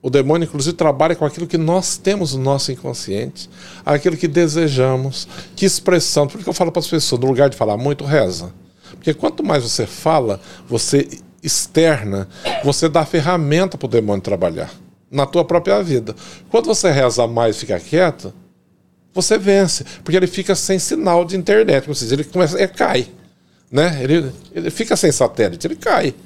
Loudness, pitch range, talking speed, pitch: -17 LUFS, 135-180 Hz, 180 wpm, 155 Hz